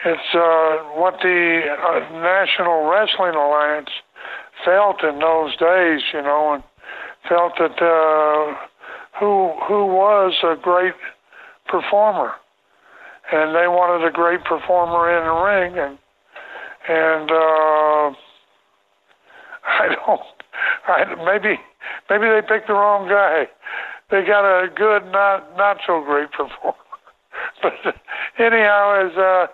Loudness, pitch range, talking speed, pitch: -17 LUFS, 155-195 Hz, 120 wpm, 170 Hz